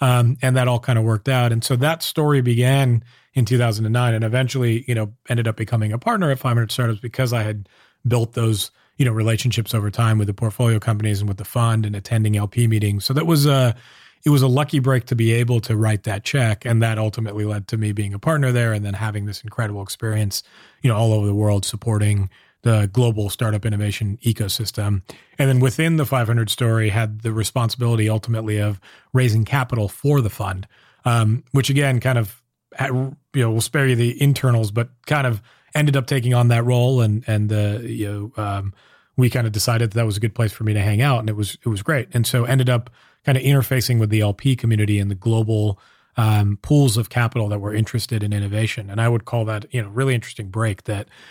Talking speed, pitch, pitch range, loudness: 225 wpm, 115 Hz, 110-125 Hz, -20 LUFS